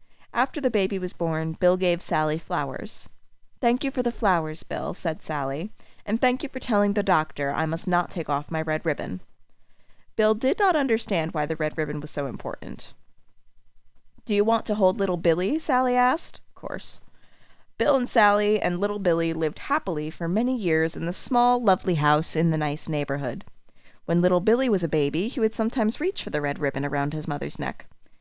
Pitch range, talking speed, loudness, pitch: 155-220 Hz, 195 wpm, -25 LUFS, 180 Hz